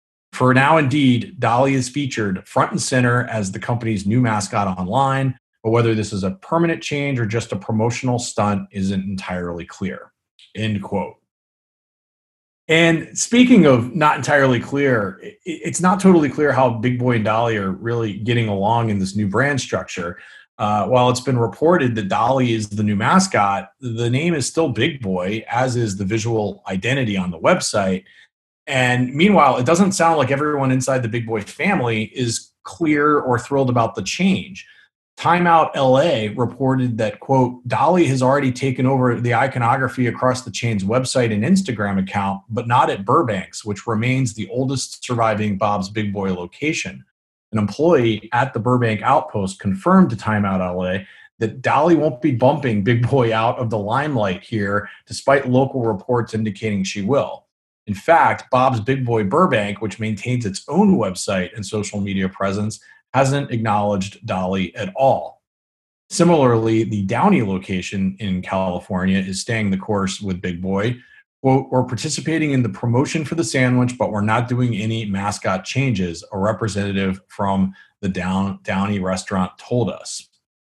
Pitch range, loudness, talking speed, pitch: 100-130 Hz, -19 LUFS, 160 wpm, 115 Hz